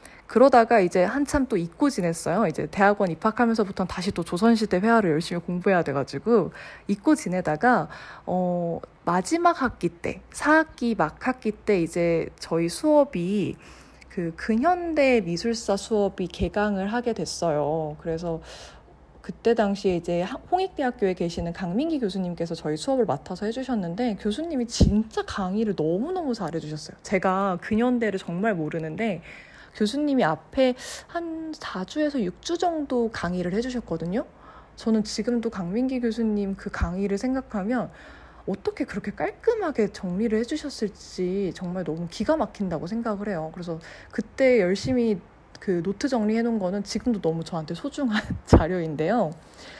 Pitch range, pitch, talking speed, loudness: 175-245 Hz, 205 Hz, 330 characters per minute, -25 LUFS